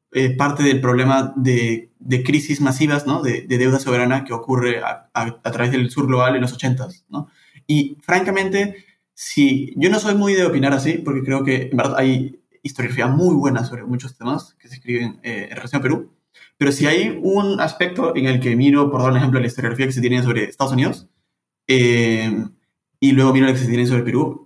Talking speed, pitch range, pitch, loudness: 215 wpm, 125-145 Hz, 130 Hz, -18 LUFS